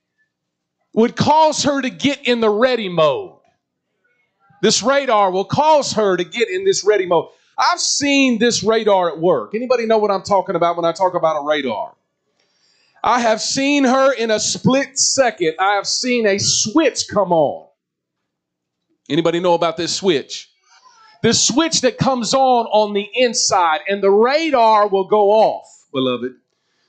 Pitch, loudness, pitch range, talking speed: 220 Hz, -16 LUFS, 195-270 Hz, 165 wpm